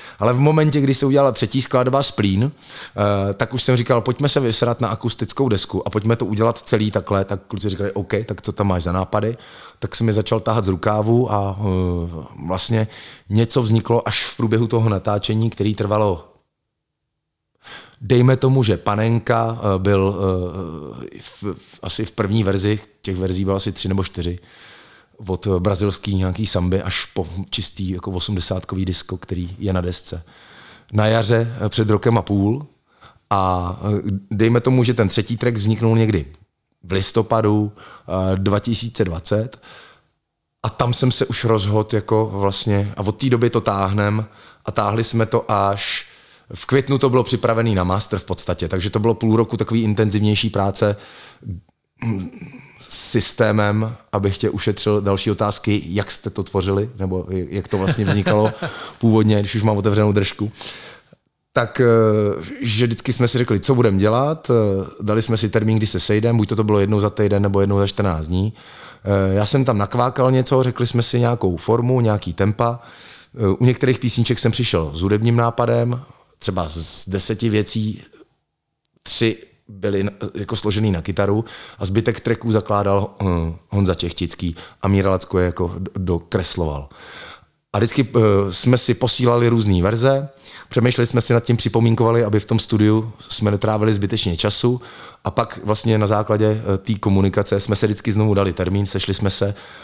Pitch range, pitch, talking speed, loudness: 100-115 Hz, 105 Hz, 160 wpm, -19 LUFS